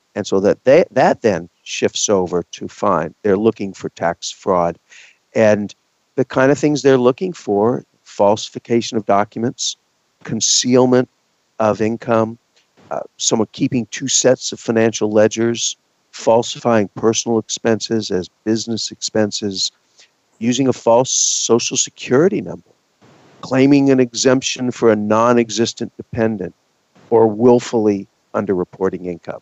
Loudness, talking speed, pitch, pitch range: -16 LUFS, 120 wpm, 115 Hz, 105-125 Hz